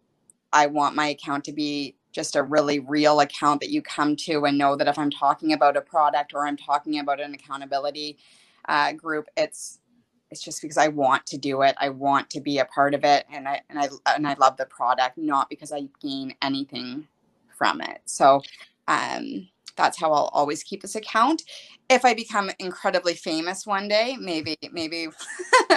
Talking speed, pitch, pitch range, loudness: 195 wpm, 145 Hz, 140-165 Hz, -24 LUFS